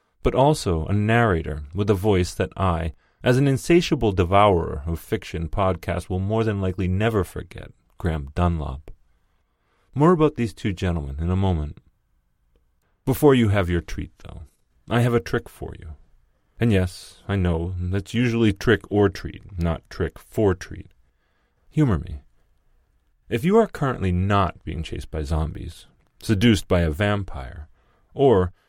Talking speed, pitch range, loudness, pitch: 155 wpm, 85-110 Hz, -22 LUFS, 95 Hz